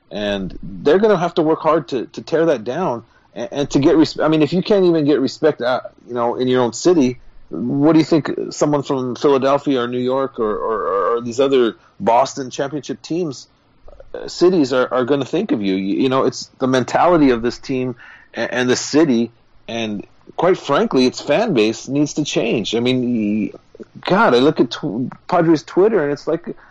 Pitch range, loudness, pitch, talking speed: 120-160 Hz, -17 LUFS, 135 Hz, 210 wpm